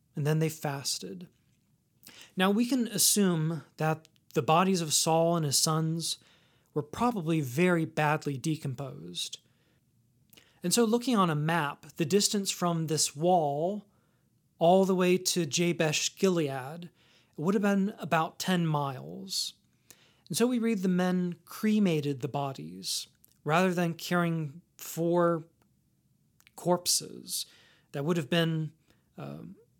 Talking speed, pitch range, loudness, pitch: 125 wpm, 150-180 Hz, -29 LUFS, 165 Hz